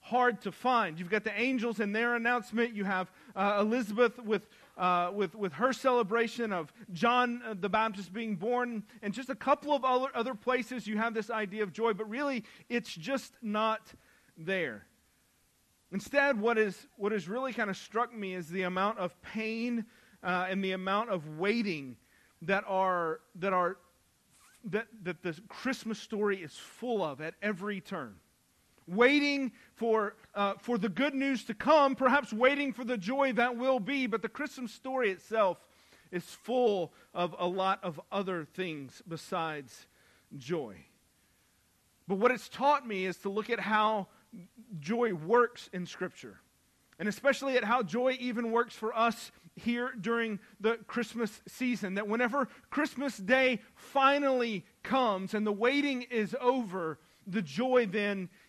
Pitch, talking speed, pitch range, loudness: 220 Hz, 160 wpm, 190-245 Hz, -32 LUFS